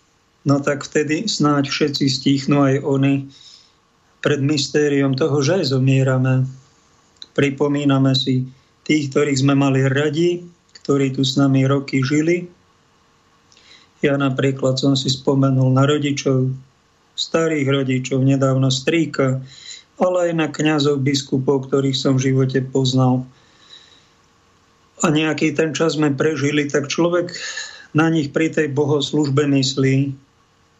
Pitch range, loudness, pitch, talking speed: 135-150 Hz, -18 LUFS, 140 Hz, 120 wpm